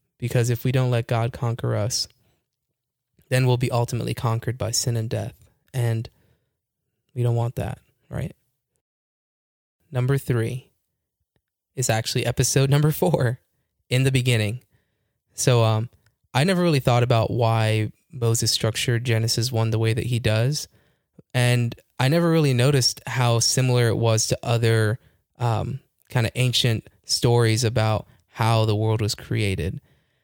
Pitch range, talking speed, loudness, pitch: 110-130 Hz, 145 wpm, -22 LUFS, 120 Hz